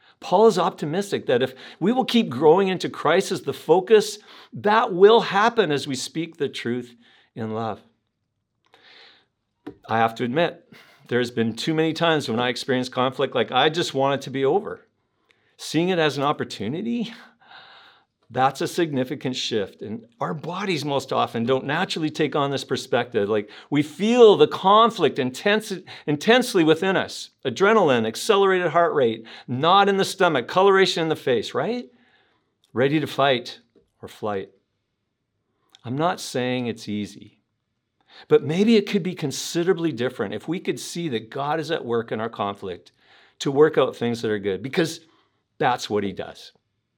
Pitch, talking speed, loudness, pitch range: 150 Hz, 165 wpm, -22 LUFS, 125-185 Hz